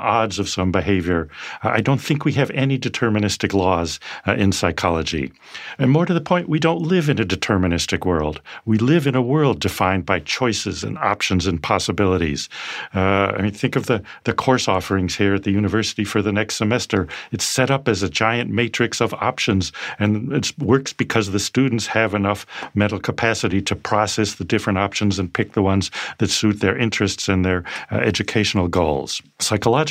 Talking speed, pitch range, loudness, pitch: 190 wpm, 95-120 Hz, -20 LUFS, 105 Hz